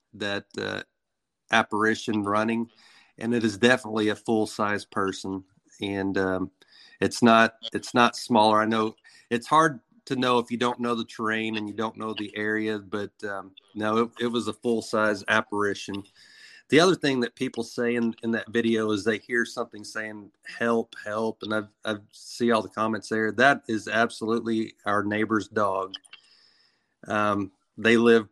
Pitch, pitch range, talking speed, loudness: 110 Hz, 105-115 Hz, 170 wpm, -25 LUFS